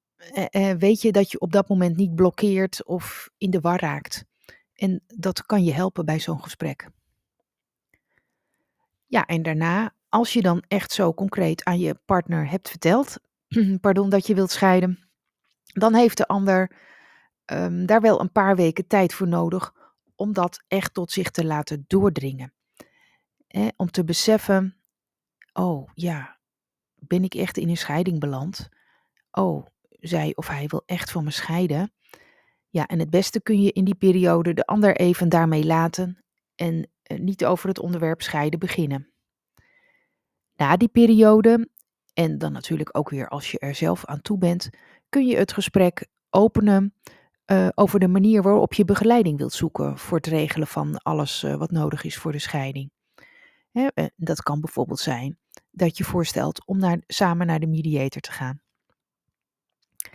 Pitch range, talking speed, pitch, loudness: 165-200 Hz, 165 wpm, 180 Hz, -22 LUFS